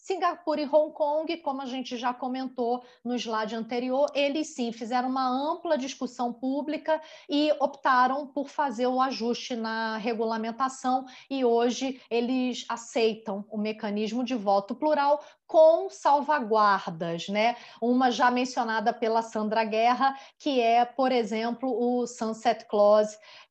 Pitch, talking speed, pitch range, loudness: 250 Hz, 135 wpm, 230-280 Hz, -27 LUFS